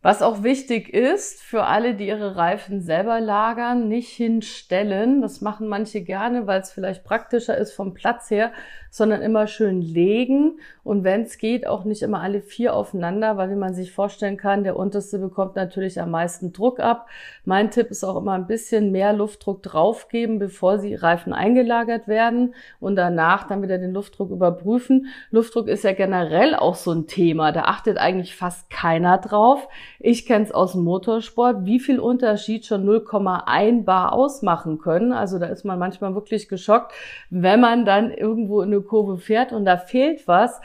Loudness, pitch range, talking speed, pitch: -21 LUFS, 190-230 Hz, 180 wpm, 205 Hz